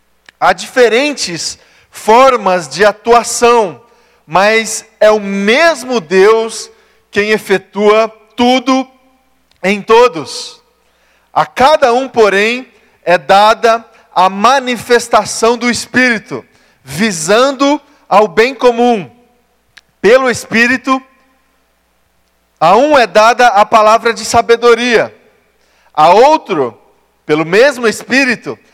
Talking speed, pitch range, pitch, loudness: 90 wpm, 205-250 Hz, 230 Hz, -10 LUFS